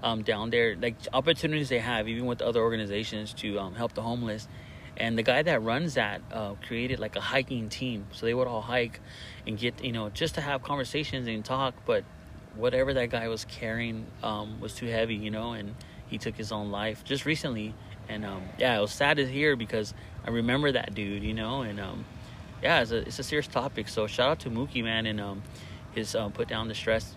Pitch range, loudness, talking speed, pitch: 105-125 Hz, -30 LUFS, 225 wpm, 115 Hz